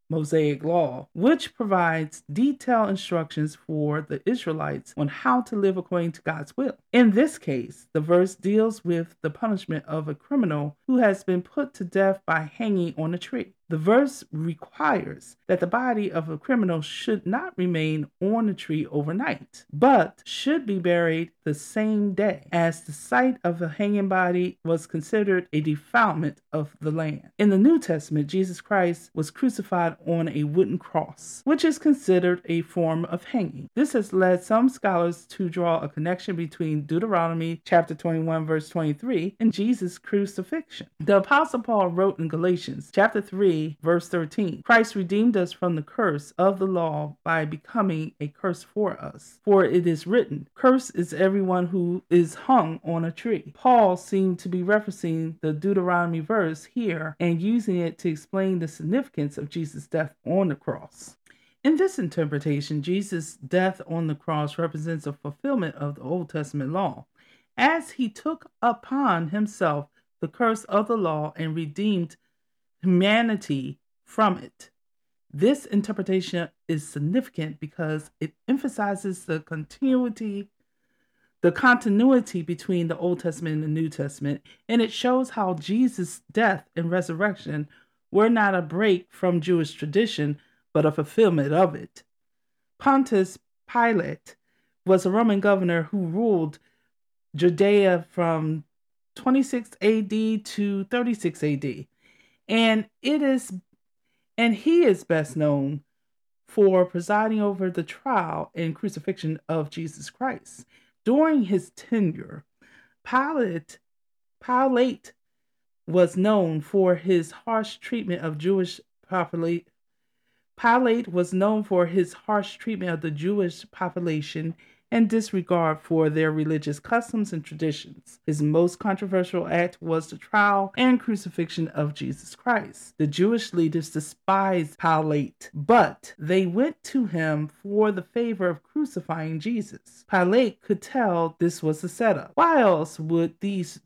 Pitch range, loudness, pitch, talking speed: 160-215 Hz, -24 LUFS, 180 Hz, 145 wpm